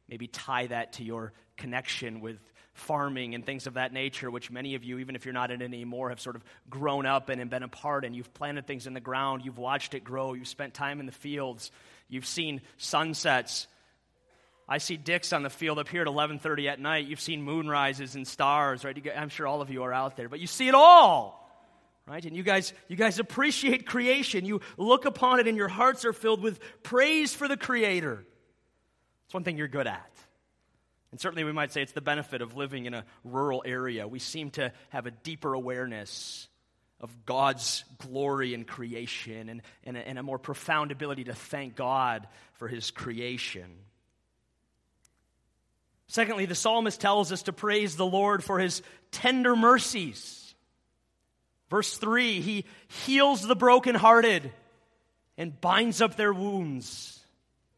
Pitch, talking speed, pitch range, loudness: 140 Hz, 185 wpm, 125-190 Hz, -27 LUFS